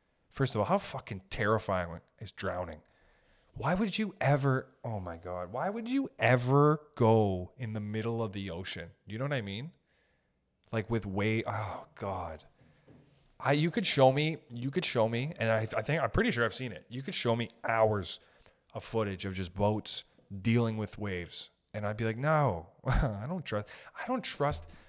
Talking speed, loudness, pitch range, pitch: 190 wpm, -32 LUFS, 100-135 Hz, 110 Hz